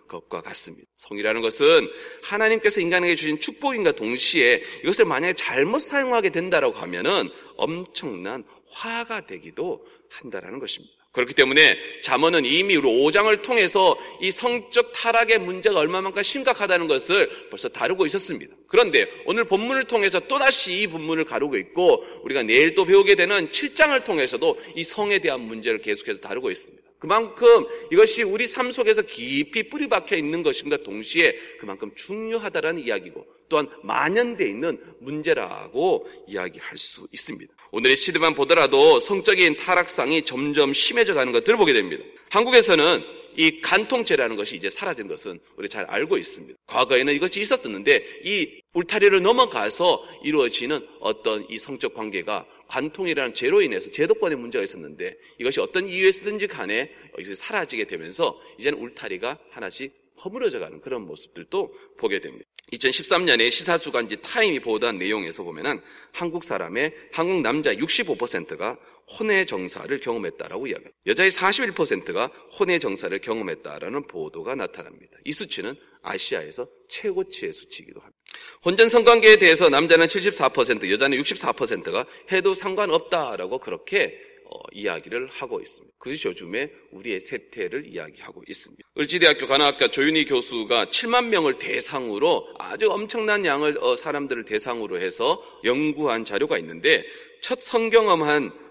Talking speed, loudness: 360 characters per minute, -21 LUFS